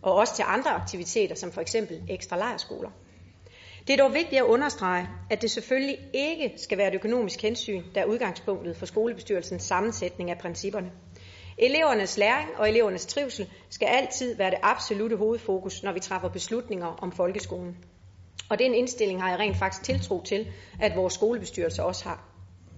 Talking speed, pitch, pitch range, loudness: 170 wpm, 200 Hz, 170-230 Hz, -27 LUFS